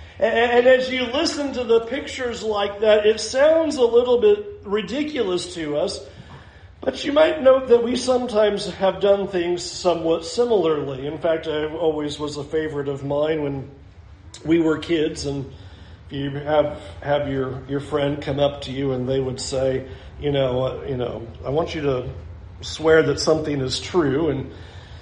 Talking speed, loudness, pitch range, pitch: 170 wpm, -21 LUFS, 135-220 Hz, 155 Hz